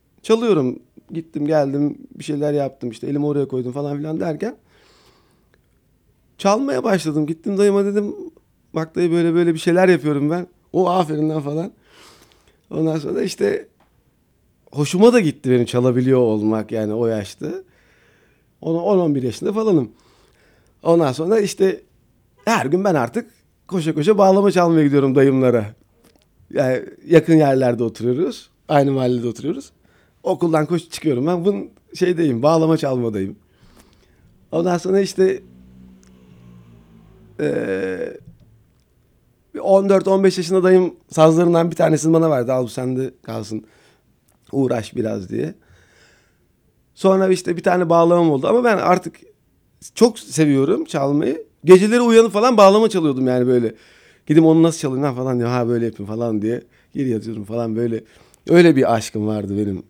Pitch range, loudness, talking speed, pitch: 125-180 Hz, -18 LUFS, 135 wpm, 155 Hz